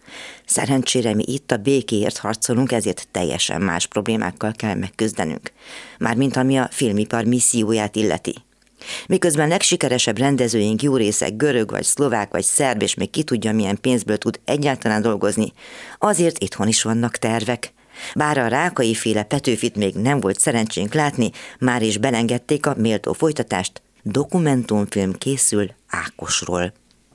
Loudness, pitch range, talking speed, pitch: -20 LUFS, 105-135 Hz, 135 wpm, 115 Hz